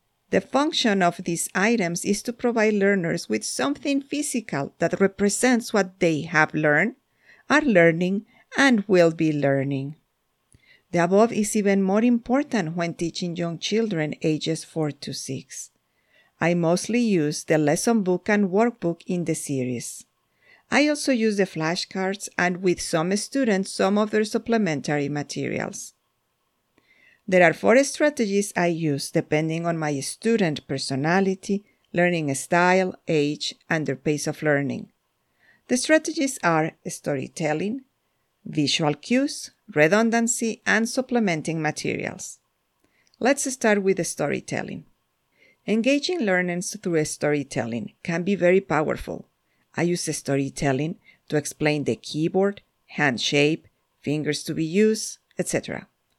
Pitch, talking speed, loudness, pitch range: 180 Hz, 130 wpm, -23 LUFS, 155-220 Hz